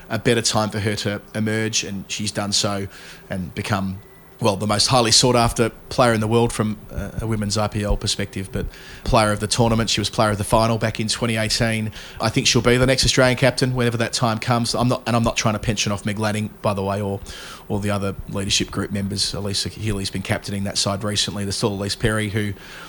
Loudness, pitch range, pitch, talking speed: -20 LUFS, 100-115 Hz, 105 Hz, 230 wpm